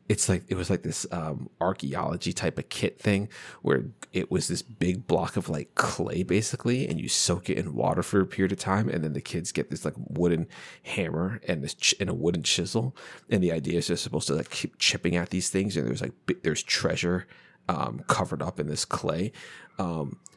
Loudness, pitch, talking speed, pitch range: -28 LUFS, 95 Hz, 220 wpm, 85-100 Hz